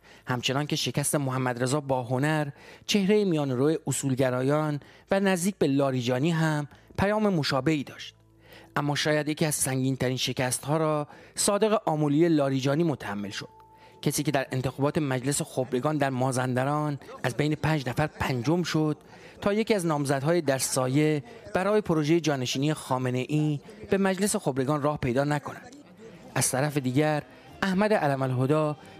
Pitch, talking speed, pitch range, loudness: 145 Hz, 145 wpm, 130-155 Hz, -27 LUFS